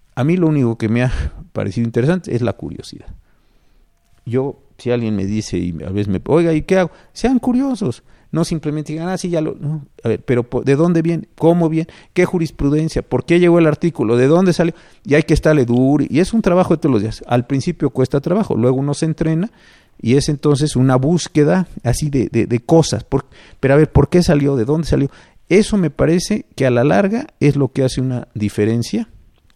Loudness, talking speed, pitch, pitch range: -16 LUFS, 215 wpm, 150 Hz, 125-170 Hz